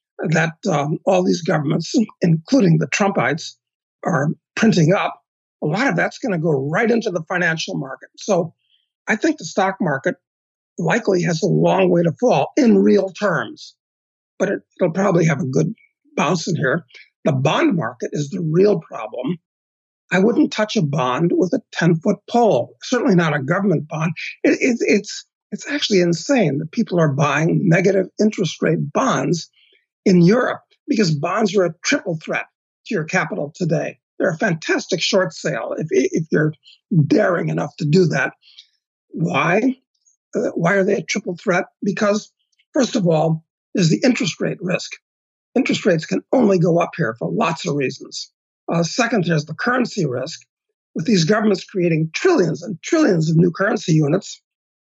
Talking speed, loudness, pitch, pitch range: 165 wpm, -19 LUFS, 185 Hz, 165-220 Hz